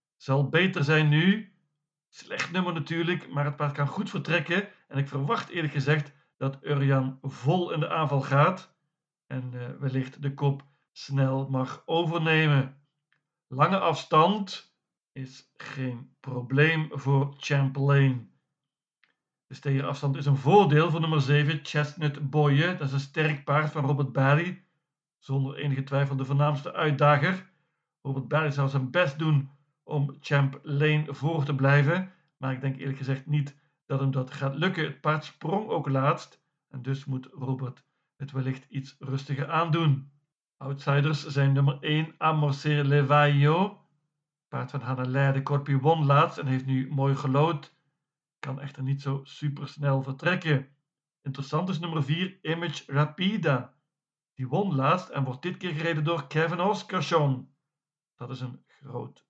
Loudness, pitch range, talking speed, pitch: -27 LUFS, 135-155 Hz, 150 wpm, 145 Hz